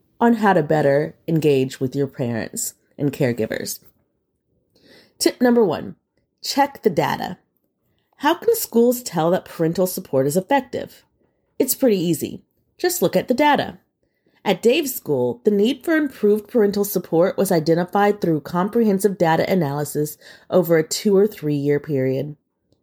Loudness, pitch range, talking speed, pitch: -20 LUFS, 150-235 Hz, 145 wpm, 185 Hz